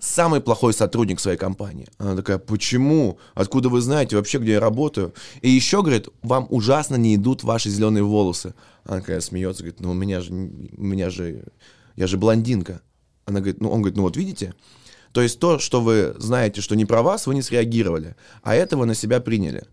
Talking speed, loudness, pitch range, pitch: 200 wpm, -21 LUFS, 95-125 Hz, 110 Hz